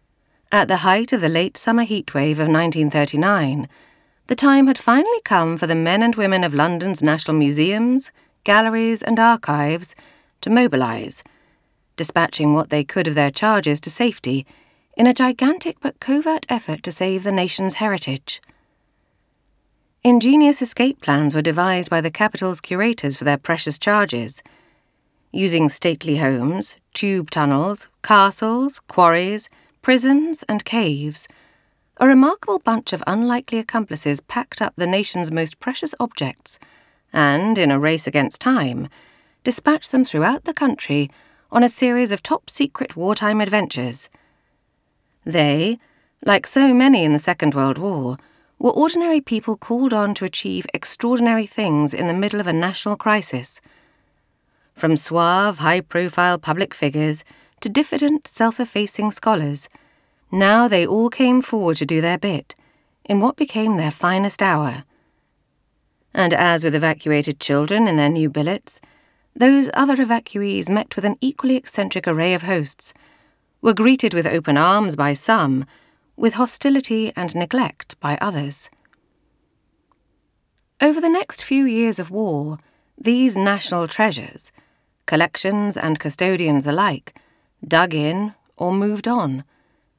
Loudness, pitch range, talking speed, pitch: -18 LUFS, 155-235 Hz, 140 wpm, 195 Hz